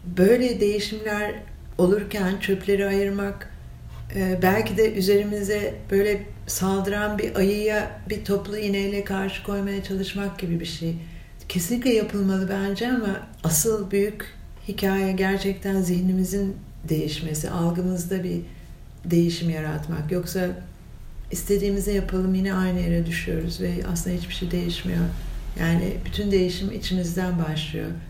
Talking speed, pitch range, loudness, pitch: 110 wpm, 175-200 Hz, -24 LUFS, 190 Hz